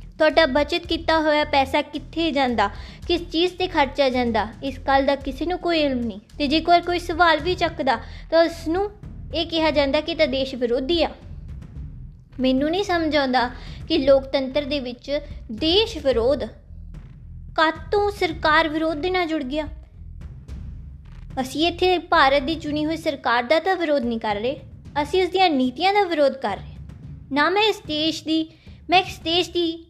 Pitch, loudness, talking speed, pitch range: 310 Hz, -21 LUFS, 170 wpm, 270-335 Hz